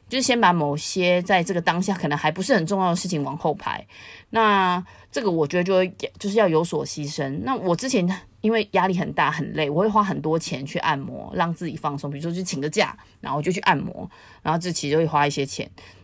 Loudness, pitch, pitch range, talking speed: -23 LUFS, 175 Hz, 150-190 Hz, 330 characters per minute